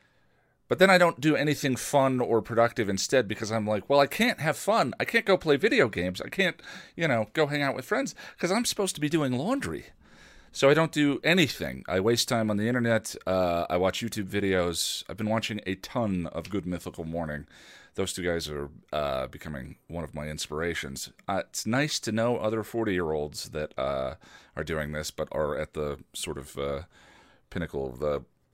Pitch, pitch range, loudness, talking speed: 105 Hz, 80-135 Hz, -27 LUFS, 210 wpm